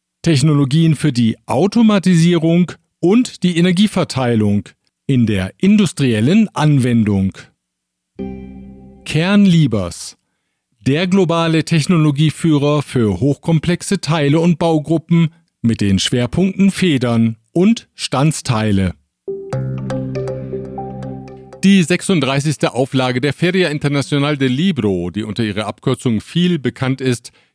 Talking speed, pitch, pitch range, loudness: 90 wpm, 140 Hz, 105-170 Hz, -15 LUFS